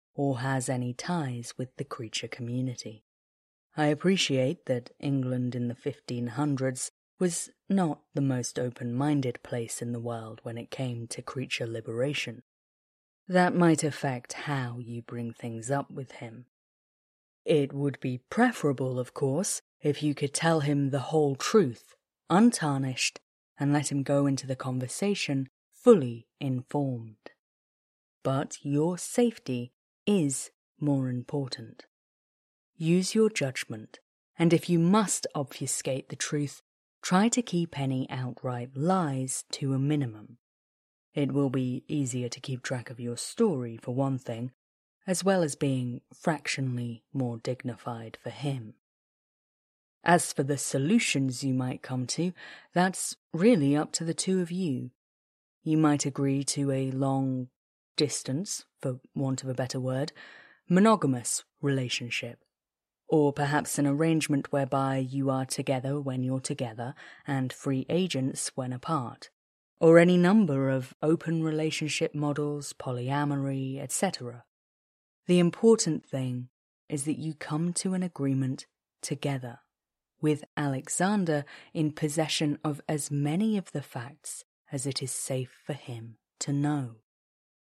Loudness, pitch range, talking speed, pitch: -29 LUFS, 125-155 Hz, 135 wpm, 140 Hz